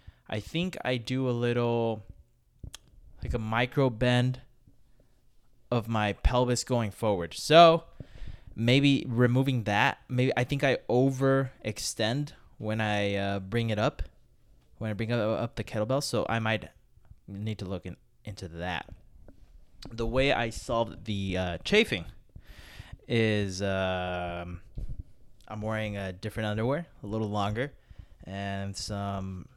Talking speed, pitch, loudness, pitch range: 130 wpm, 110 Hz, -29 LUFS, 100-125 Hz